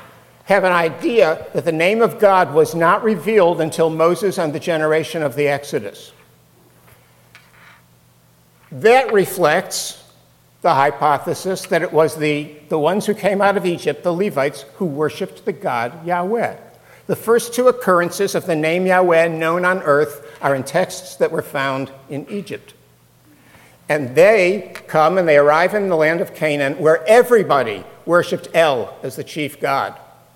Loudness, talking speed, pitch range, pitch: -17 LUFS, 155 wpm, 140-185 Hz, 160 Hz